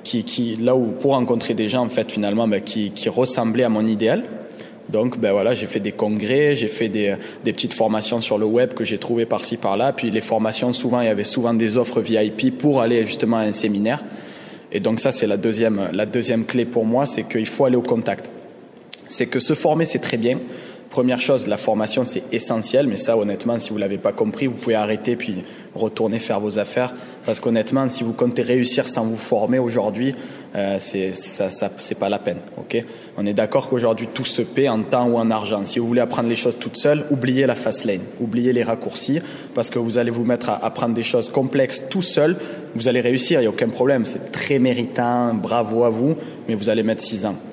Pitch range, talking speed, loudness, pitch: 110-125 Hz, 230 wpm, -21 LUFS, 120 Hz